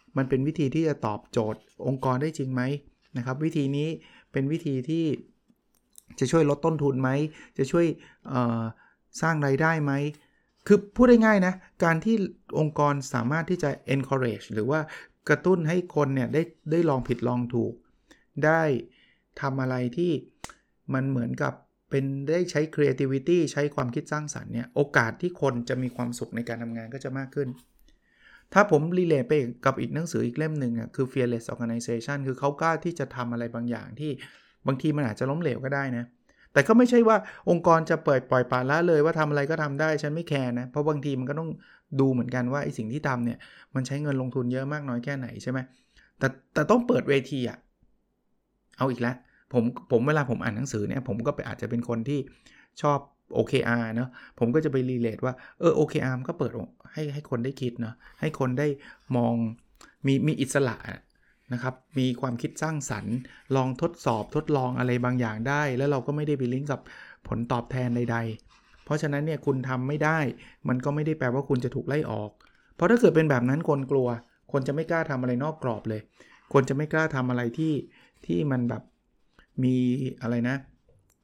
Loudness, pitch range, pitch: -27 LUFS, 125-150 Hz, 135 Hz